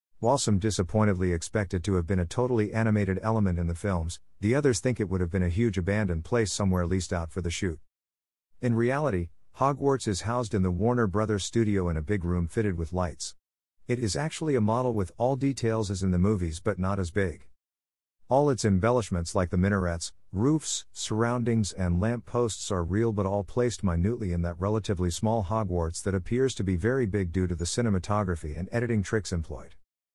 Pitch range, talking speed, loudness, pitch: 90-115 Hz, 200 wpm, -28 LUFS, 100 Hz